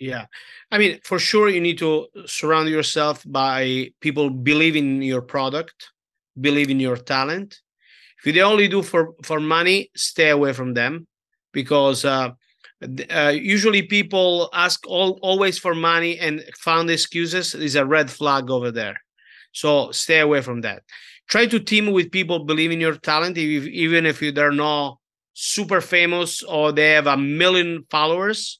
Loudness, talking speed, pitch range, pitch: -19 LUFS, 160 wpm, 145-175 Hz, 155 Hz